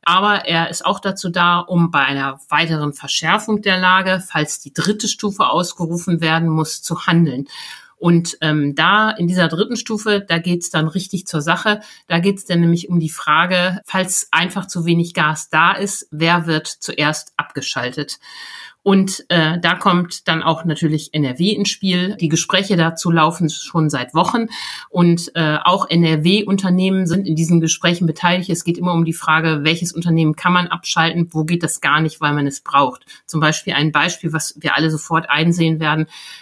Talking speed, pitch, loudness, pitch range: 185 wpm, 170 Hz, -17 LUFS, 155-185 Hz